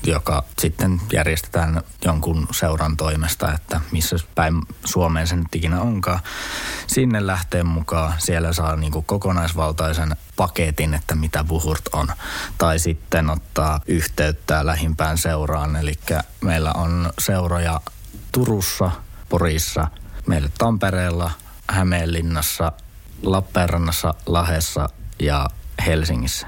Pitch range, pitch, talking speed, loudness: 80-90 Hz, 85 Hz, 100 wpm, -21 LUFS